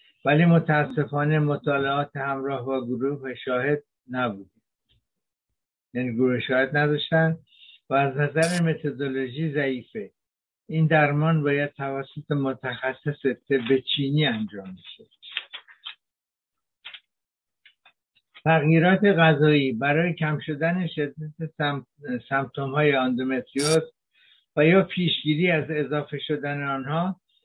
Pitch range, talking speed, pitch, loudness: 135-155 Hz, 90 wpm, 145 Hz, -24 LUFS